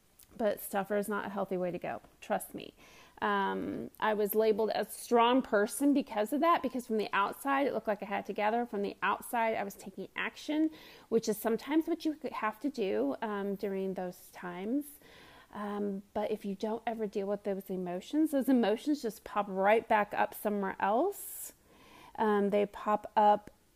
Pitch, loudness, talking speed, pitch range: 215 Hz, -33 LUFS, 185 wpm, 205-250 Hz